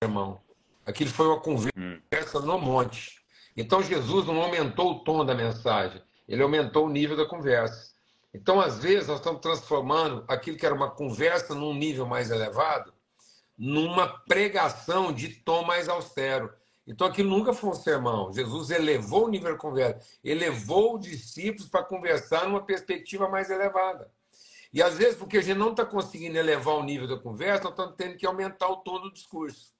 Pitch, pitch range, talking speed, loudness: 165 Hz, 135-190 Hz, 175 wpm, -27 LUFS